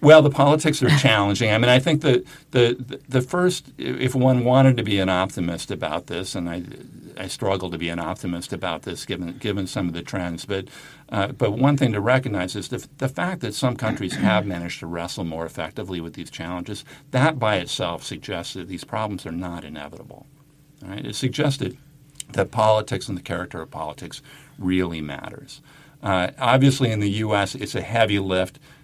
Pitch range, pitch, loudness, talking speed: 90-135 Hz, 110 Hz, -22 LUFS, 190 wpm